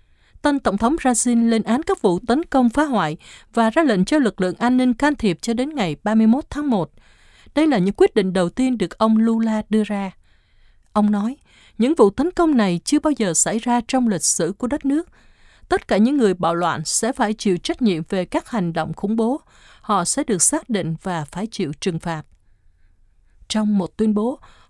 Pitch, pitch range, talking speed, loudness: 215 Hz, 180-250 Hz, 215 wpm, -19 LUFS